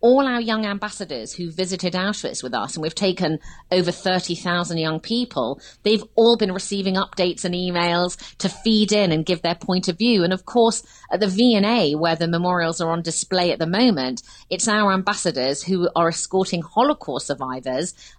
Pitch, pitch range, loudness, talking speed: 185 Hz, 170-210 Hz, -21 LUFS, 180 wpm